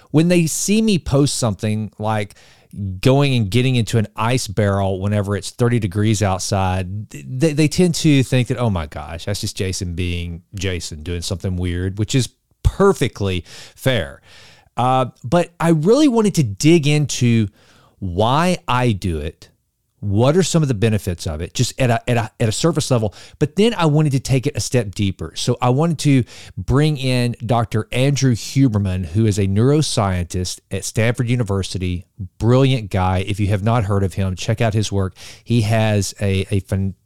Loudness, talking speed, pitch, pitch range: -18 LUFS, 185 wpm, 110 Hz, 100-130 Hz